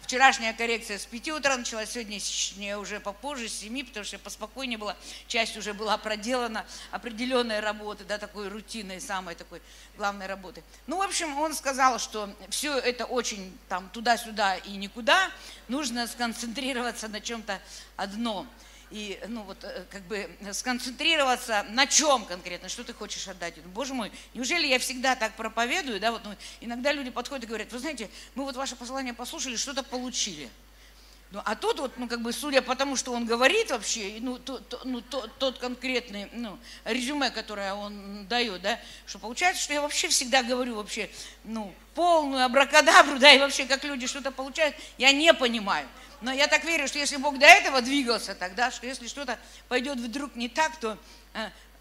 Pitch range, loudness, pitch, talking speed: 210-270 Hz, -26 LUFS, 240 Hz, 175 wpm